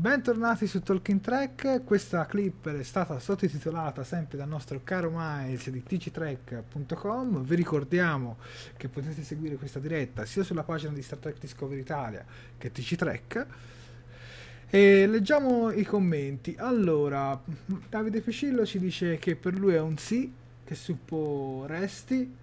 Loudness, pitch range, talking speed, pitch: -29 LUFS, 135-195 Hz, 135 wpm, 160 Hz